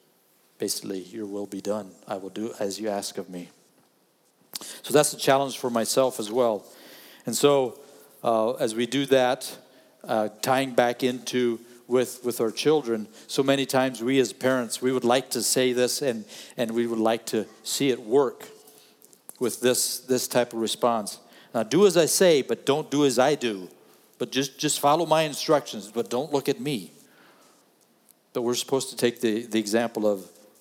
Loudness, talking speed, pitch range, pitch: -25 LUFS, 185 wpm, 110-135 Hz, 125 Hz